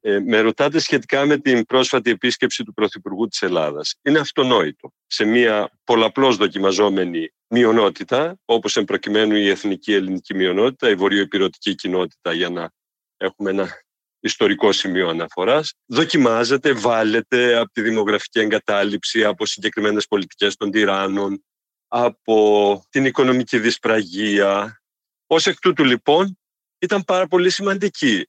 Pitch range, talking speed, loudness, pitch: 105-135 Hz, 125 wpm, -18 LUFS, 115 Hz